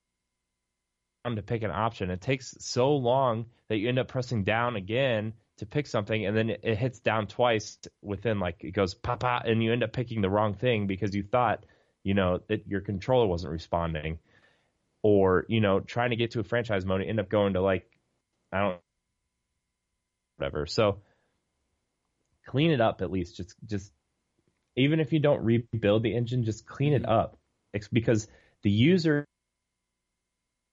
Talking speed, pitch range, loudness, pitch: 180 wpm, 90-120 Hz, -28 LUFS, 105 Hz